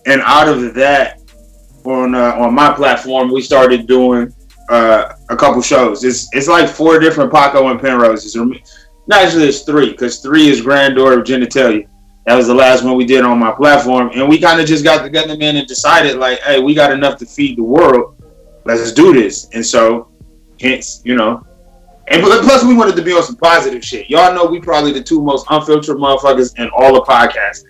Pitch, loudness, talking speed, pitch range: 135 Hz, -10 LUFS, 200 wpm, 120-150 Hz